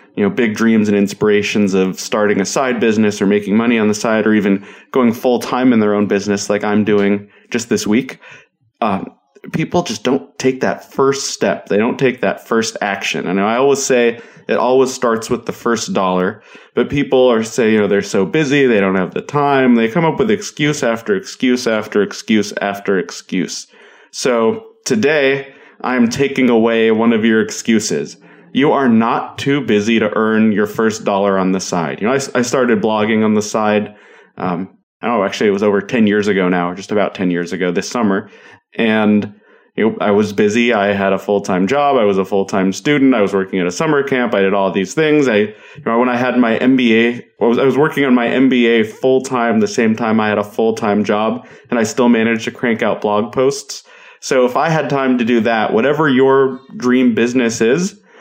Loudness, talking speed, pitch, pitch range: -15 LUFS, 215 wpm, 115 Hz, 105-130 Hz